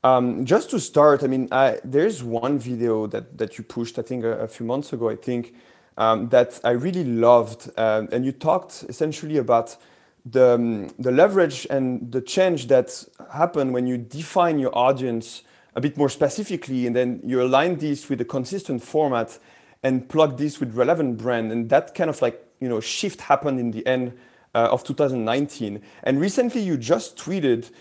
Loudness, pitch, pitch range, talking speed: -22 LUFS, 130 Hz, 120-145 Hz, 190 wpm